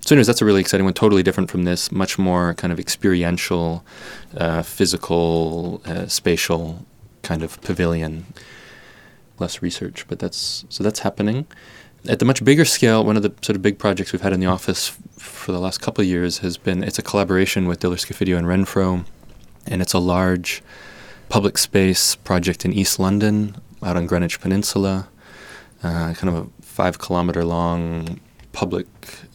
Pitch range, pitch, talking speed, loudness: 85-100 Hz, 95 Hz, 175 wpm, -20 LUFS